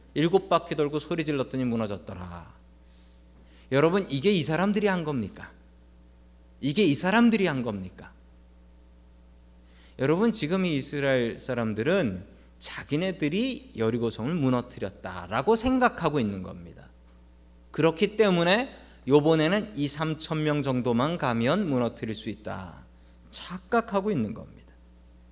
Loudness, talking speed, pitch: -26 LUFS, 275 characters per minute, 120 Hz